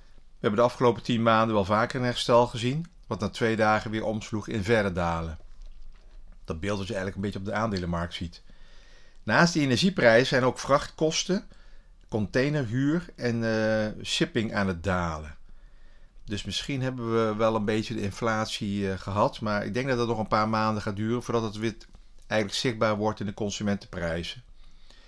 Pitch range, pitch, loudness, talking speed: 100-120 Hz, 110 Hz, -27 LUFS, 180 wpm